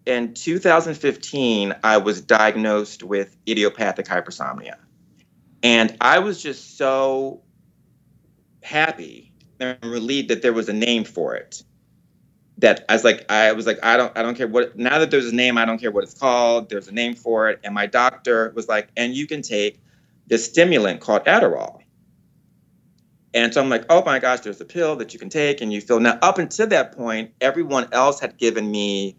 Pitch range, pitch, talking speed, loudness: 110-135 Hz, 120 Hz, 190 wpm, -19 LUFS